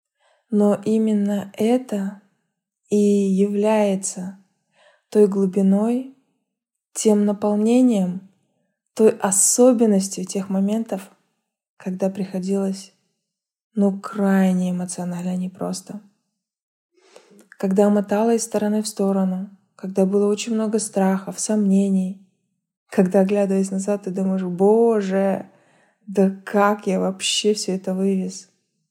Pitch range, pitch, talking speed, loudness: 195-210 Hz, 200 Hz, 95 wpm, -20 LUFS